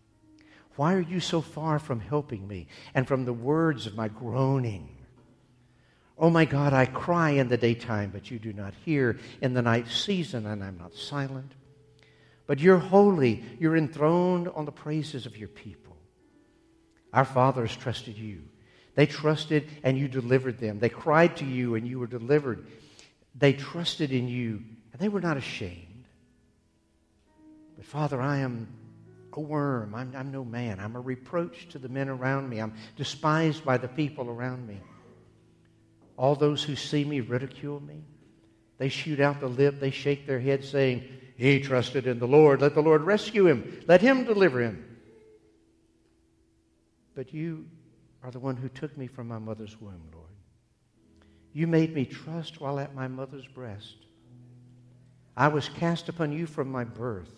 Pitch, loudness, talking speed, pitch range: 130 Hz, -27 LUFS, 165 wpm, 115-145 Hz